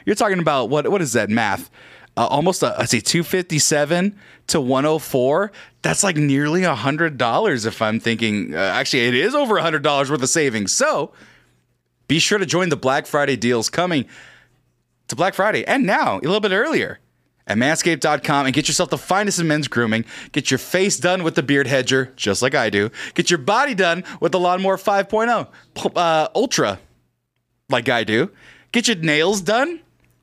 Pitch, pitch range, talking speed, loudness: 155 Hz, 130-180 Hz, 185 wpm, -19 LUFS